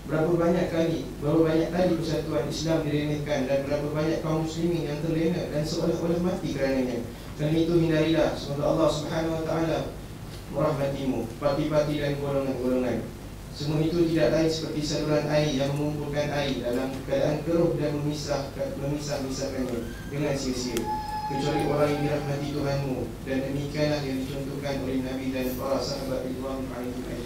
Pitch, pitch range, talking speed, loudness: 145 Hz, 135-155 Hz, 150 wpm, -27 LUFS